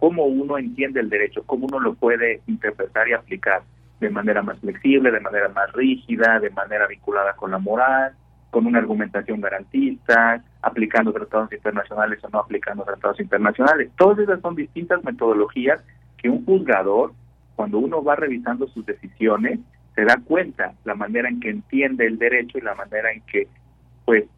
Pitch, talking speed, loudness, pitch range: 120 Hz, 165 wpm, -21 LUFS, 105-165 Hz